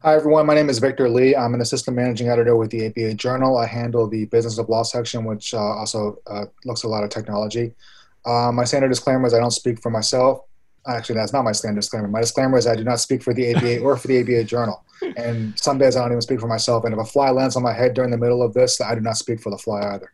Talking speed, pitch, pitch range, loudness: 280 wpm, 120 Hz, 110-125 Hz, -20 LUFS